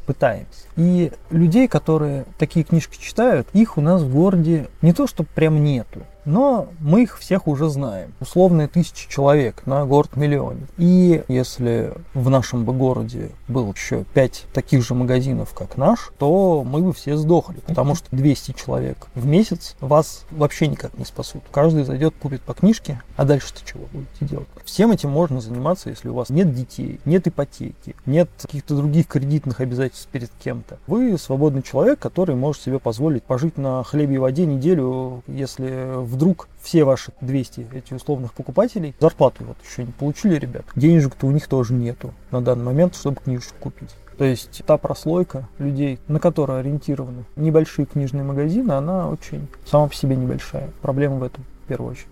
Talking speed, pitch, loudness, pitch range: 170 wpm, 145 Hz, -20 LUFS, 130-165 Hz